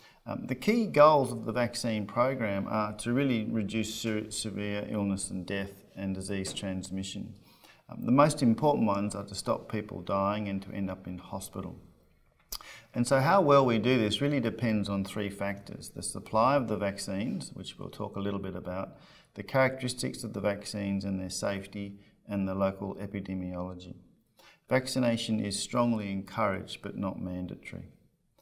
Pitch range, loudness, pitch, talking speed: 100-115 Hz, -30 LUFS, 105 Hz, 165 wpm